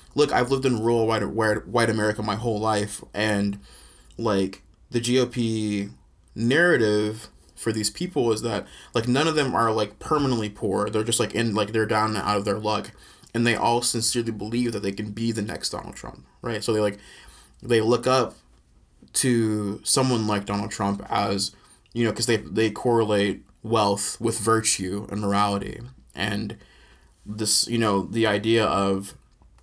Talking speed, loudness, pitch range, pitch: 170 wpm, -24 LUFS, 100-115 Hz, 110 Hz